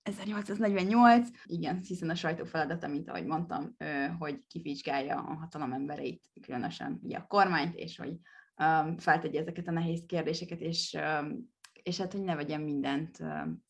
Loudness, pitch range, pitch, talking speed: -32 LUFS, 150-185 Hz, 165 Hz, 160 wpm